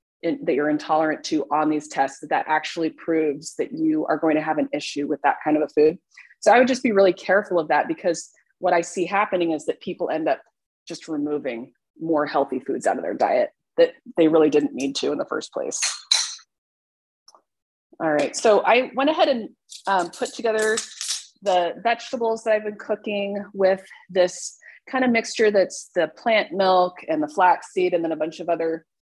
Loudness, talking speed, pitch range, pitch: -22 LUFS, 200 wpm, 150-210 Hz, 175 Hz